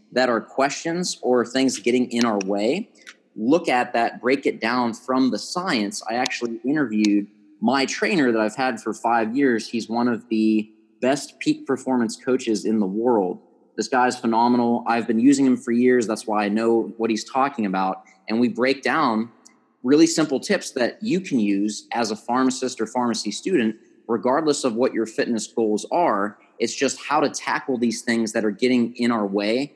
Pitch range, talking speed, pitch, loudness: 110-125 Hz, 190 wpm, 115 Hz, -22 LUFS